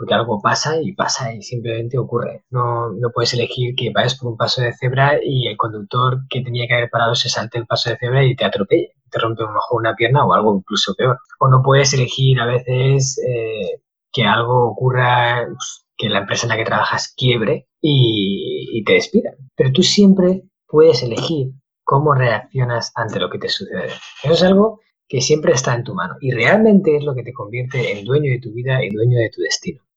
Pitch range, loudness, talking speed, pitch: 120-140 Hz, -17 LUFS, 215 wpm, 125 Hz